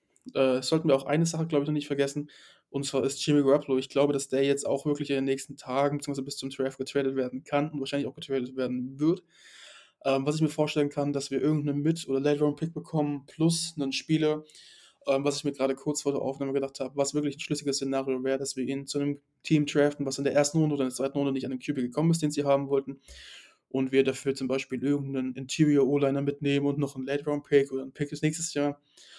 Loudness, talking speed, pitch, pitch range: -28 LUFS, 245 wpm, 140 Hz, 135-150 Hz